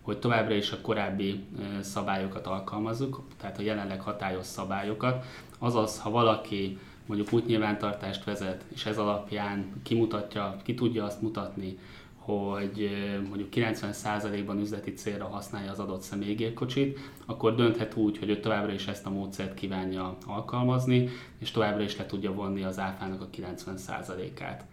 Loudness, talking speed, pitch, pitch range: -32 LUFS, 140 wpm, 105 Hz, 100-110 Hz